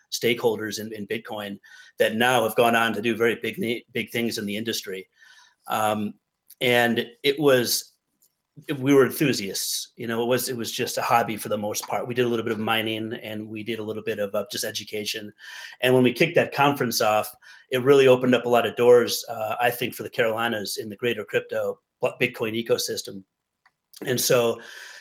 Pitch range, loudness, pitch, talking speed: 110-125 Hz, -24 LUFS, 115 Hz, 200 wpm